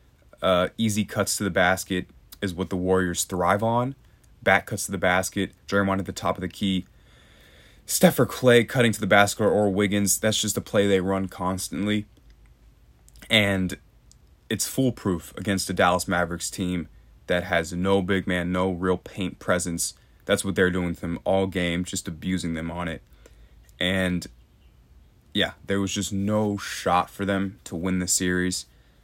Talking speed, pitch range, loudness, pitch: 170 wpm, 90-100 Hz, -24 LUFS, 95 Hz